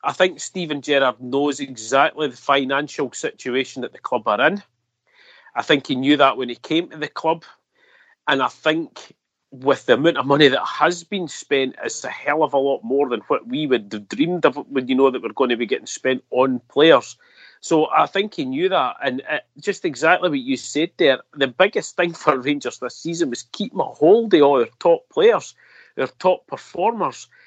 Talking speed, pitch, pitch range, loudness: 210 wpm, 145 Hz, 135-180 Hz, -20 LUFS